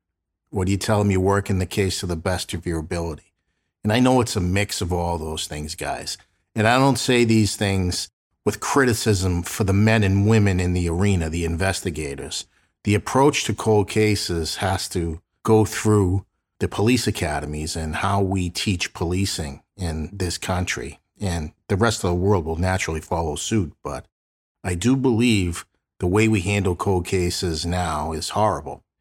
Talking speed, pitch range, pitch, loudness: 180 wpm, 85-105 Hz, 95 Hz, -22 LUFS